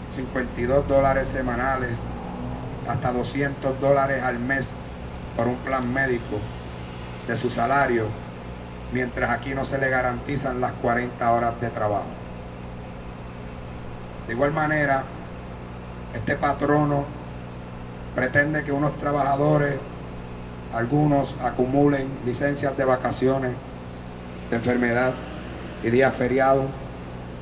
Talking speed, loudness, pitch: 100 wpm, -24 LUFS, 120 Hz